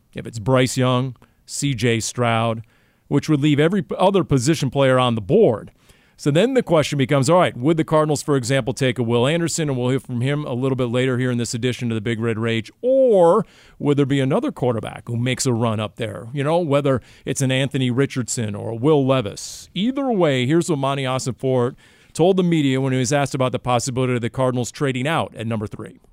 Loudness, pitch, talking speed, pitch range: -20 LUFS, 130 Hz, 225 wpm, 120-150 Hz